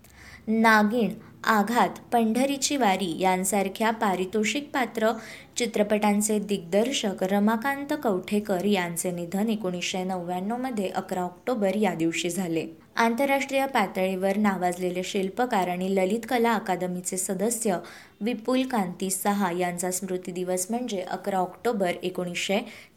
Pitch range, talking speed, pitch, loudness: 185-225 Hz, 105 wpm, 200 Hz, -26 LUFS